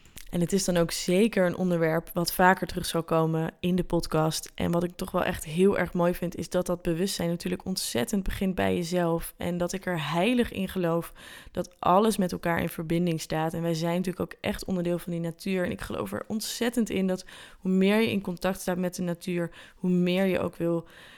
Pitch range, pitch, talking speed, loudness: 170-185 Hz, 180 Hz, 225 wpm, -28 LUFS